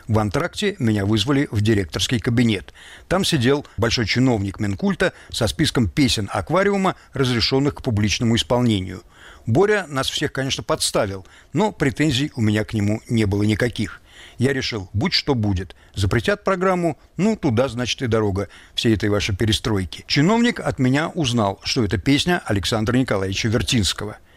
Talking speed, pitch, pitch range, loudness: 150 wpm, 115 Hz, 105-140 Hz, -20 LUFS